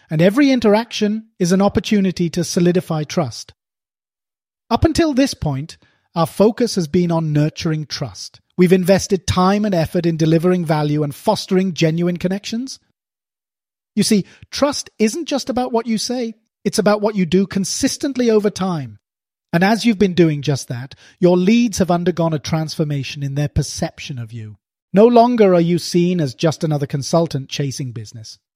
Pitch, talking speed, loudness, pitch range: 180 Hz, 165 wpm, -17 LUFS, 150-210 Hz